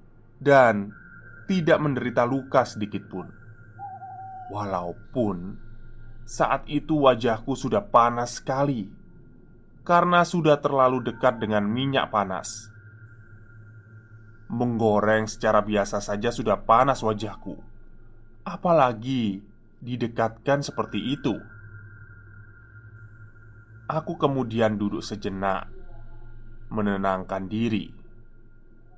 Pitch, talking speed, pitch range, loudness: 115 Hz, 75 wpm, 110-130 Hz, -24 LUFS